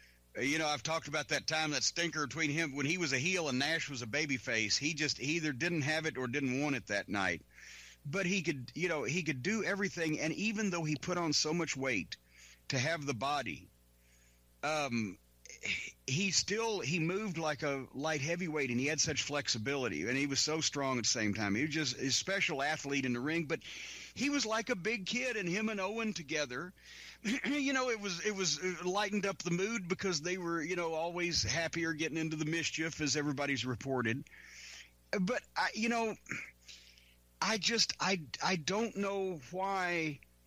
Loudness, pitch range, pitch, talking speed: -35 LUFS, 135-185 Hz, 155 Hz, 200 wpm